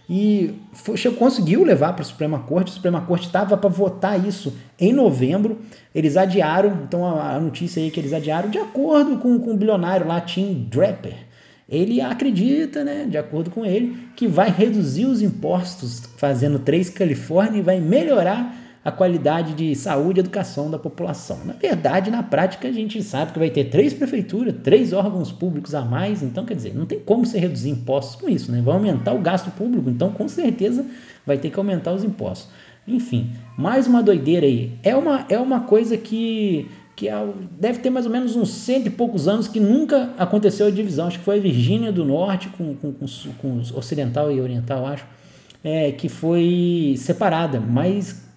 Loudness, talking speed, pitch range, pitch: -20 LUFS, 190 wpm, 155-215 Hz, 190 Hz